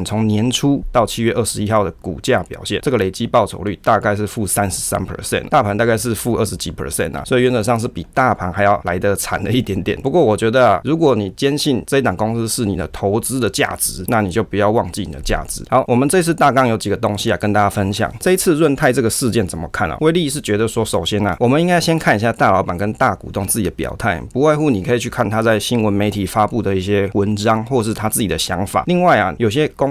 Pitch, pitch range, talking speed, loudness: 110 Hz, 100-125 Hz, 405 characters per minute, -17 LUFS